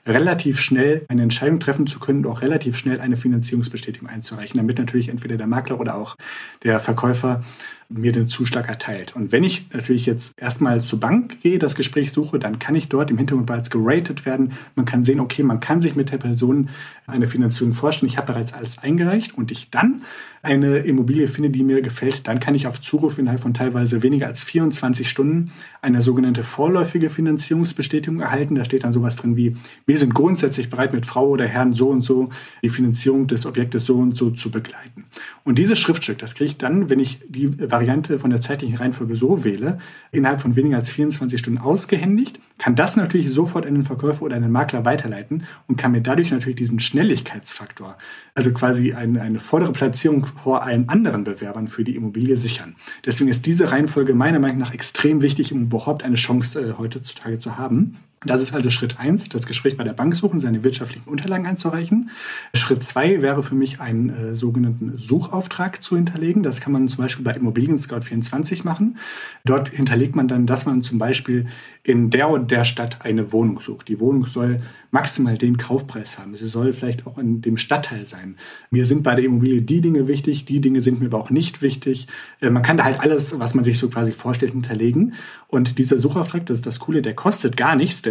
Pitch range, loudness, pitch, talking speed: 120-145 Hz, -19 LUFS, 130 Hz, 205 wpm